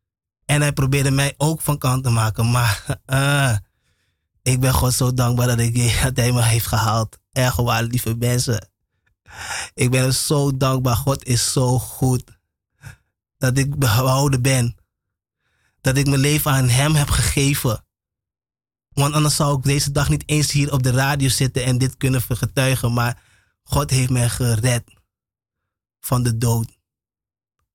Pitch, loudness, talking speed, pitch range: 125 Hz, -19 LUFS, 155 wpm, 115-135 Hz